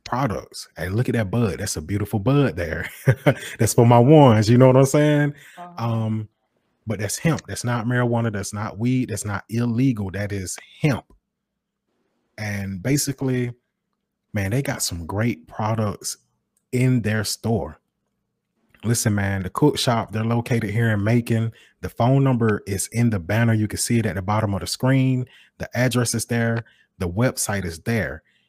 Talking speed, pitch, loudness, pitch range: 175 wpm, 115 Hz, -21 LUFS, 105-125 Hz